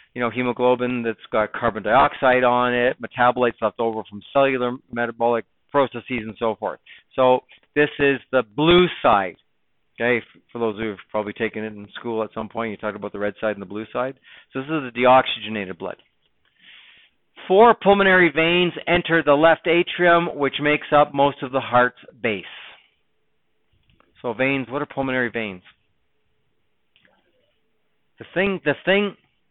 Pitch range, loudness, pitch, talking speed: 115-145 Hz, -20 LUFS, 125 Hz, 160 wpm